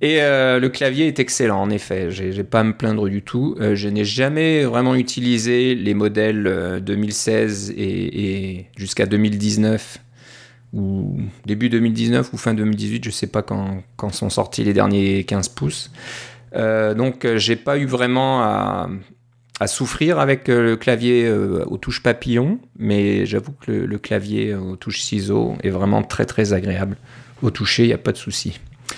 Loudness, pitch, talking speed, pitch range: -19 LUFS, 110 Hz, 175 wpm, 100-125 Hz